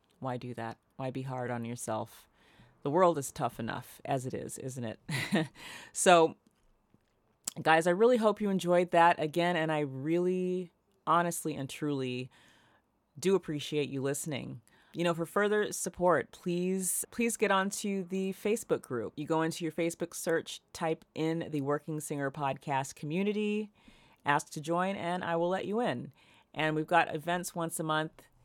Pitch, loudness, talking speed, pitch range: 165 Hz, -32 LUFS, 165 wpm, 145-180 Hz